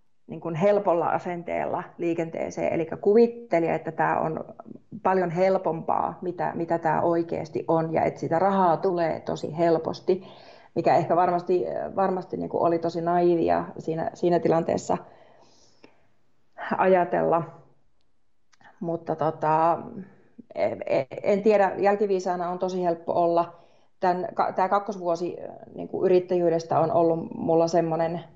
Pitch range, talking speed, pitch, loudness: 165-190 Hz, 120 wpm, 175 Hz, -25 LUFS